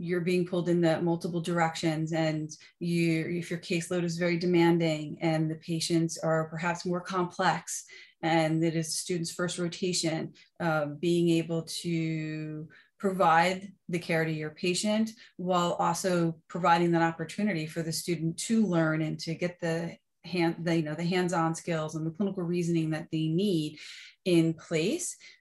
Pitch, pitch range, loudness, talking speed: 170 Hz, 160-180 Hz, -29 LUFS, 160 wpm